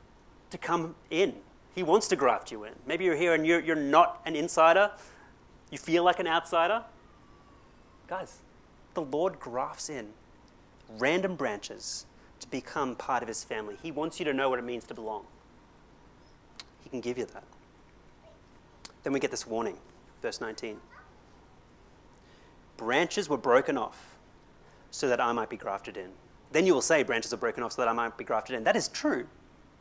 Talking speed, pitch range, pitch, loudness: 175 wpm, 130-170 Hz, 160 Hz, -29 LUFS